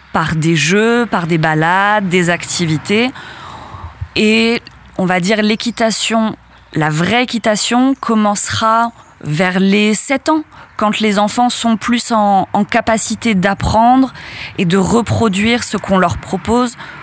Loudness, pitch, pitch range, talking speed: -12 LUFS, 215 Hz, 190-230 Hz, 130 wpm